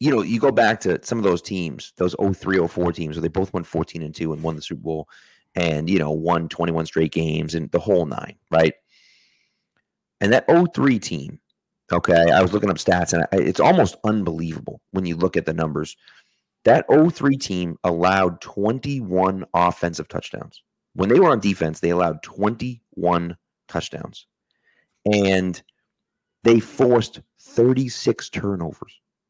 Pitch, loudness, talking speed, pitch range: 90 Hz, -21 LUFS, 165 wpm, 80-100 Hz